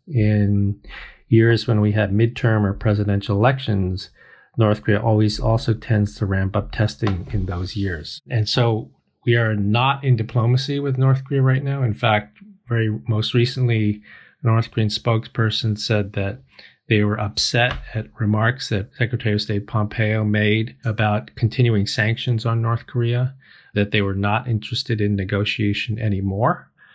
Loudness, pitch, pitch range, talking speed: -20 LUFS, 110 Hz, 105-120 Hz, 155 wpm